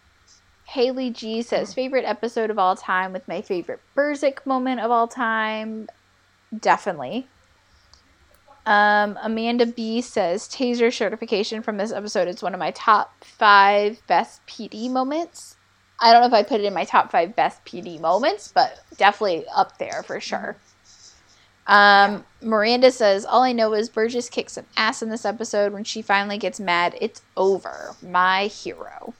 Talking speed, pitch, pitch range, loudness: 160 wpm, 220 Hz, 200-235 Hz, -21 LUFS